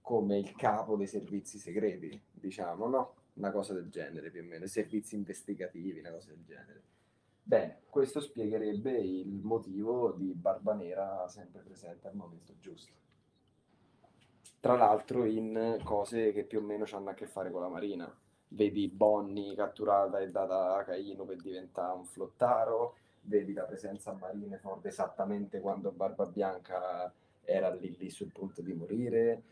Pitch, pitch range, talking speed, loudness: 100 Hz, 95-105 Hz, 155 wpm, -35 LUFS